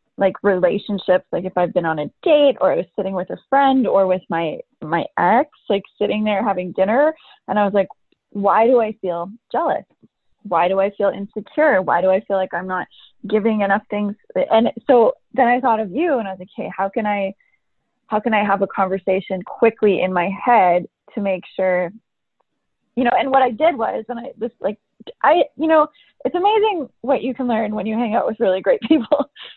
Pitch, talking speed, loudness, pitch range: 210 Hz, 215 wpm, -19 LUFS, 190-245 Hz